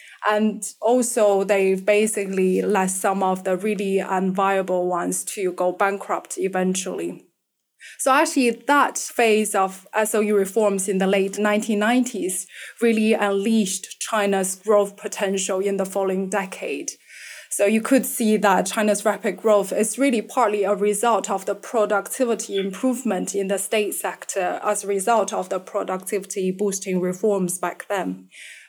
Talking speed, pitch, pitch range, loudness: 140 wpm, 200 Hz, 190-215 Hz, -22 LUFS